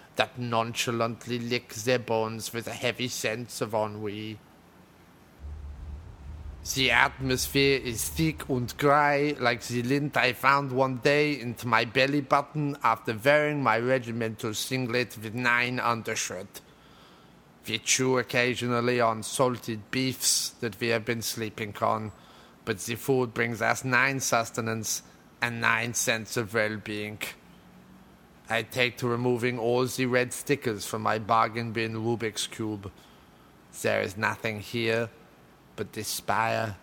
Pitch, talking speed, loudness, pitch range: 120 Hz, 130 wpm, -27 LUFS, 110-125 Hz